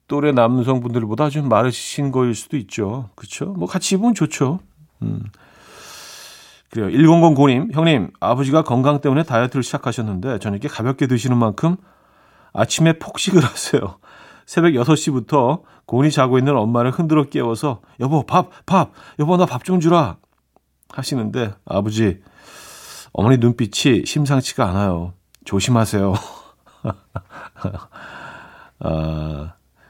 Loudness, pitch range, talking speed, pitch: -18 LUFS, 115-155 Hz, 270 characters per minute, 130 Hz